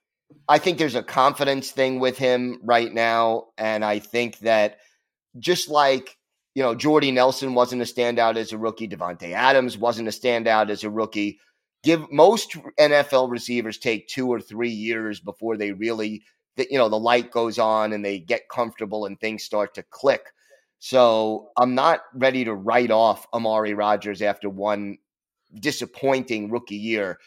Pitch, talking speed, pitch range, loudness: 115 Hz, 165 wpm, 110-130 Hz, -22 LUFS